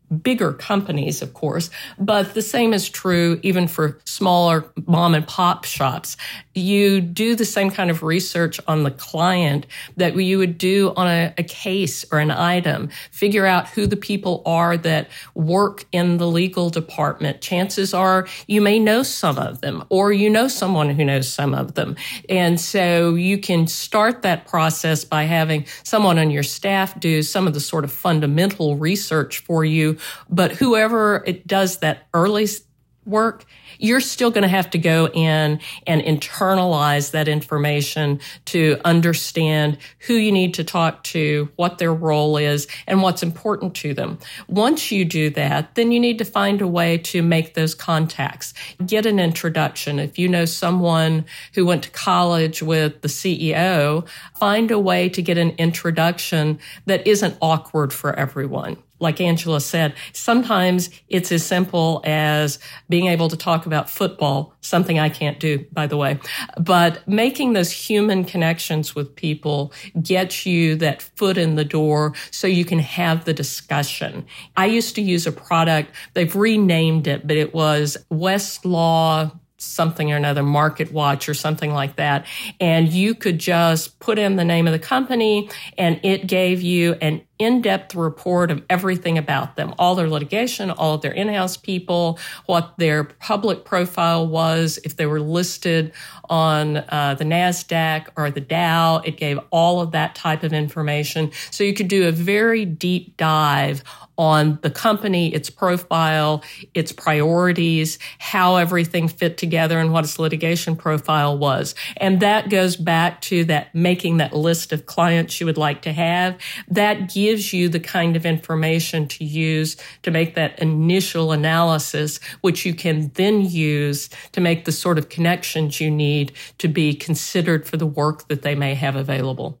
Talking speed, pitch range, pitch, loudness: 170 wpm, 155-185 Hz, 165 Hz, -19 LUFS